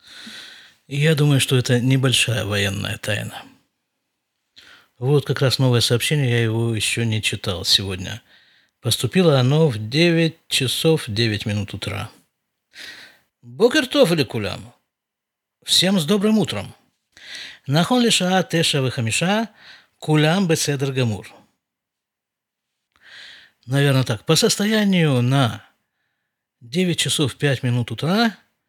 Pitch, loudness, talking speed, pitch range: 135 Hz, -19 LUFS, 105 wpm, 115-165 Hz